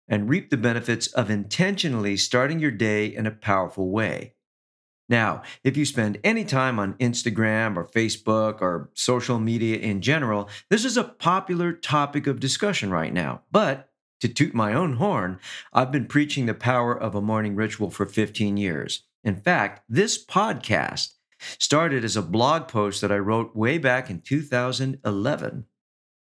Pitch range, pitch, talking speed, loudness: 105-135 Hz, 110 Hz, 160 wpm, -24 LUFS